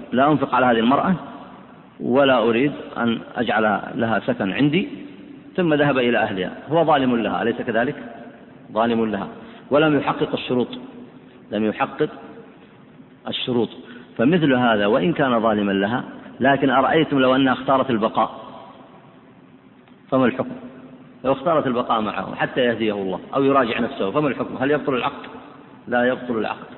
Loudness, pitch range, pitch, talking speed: -20 LUFS, 110-135 Hz, 125 Hz, 135 wpm